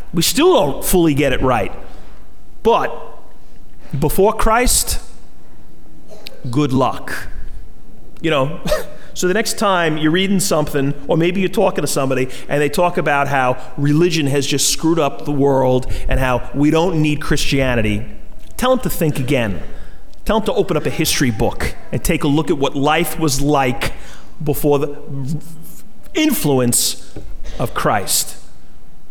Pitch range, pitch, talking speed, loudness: 135-170 Hz, 145 Hz, 150 wpm, -17 LUFS